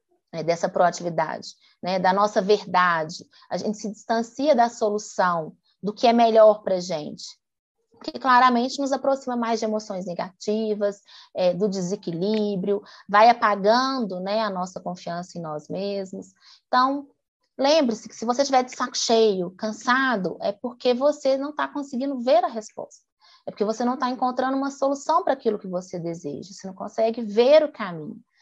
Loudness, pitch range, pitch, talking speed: -23 LUFS, 190-255 Hz, 215 Hz, 165 wpm